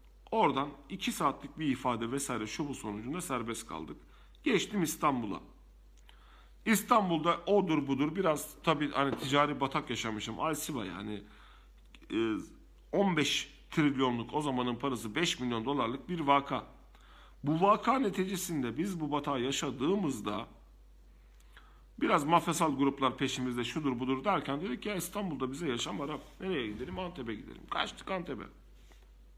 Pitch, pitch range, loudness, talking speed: 140 Hz, 125-165 Hz, -33 LUFS, 125 wpm